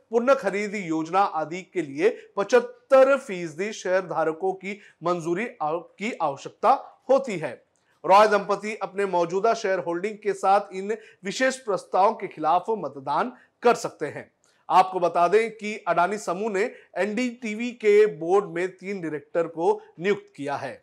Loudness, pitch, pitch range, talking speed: -24 LUFS, 200 Hz, 175-220 Hz, 145 wpm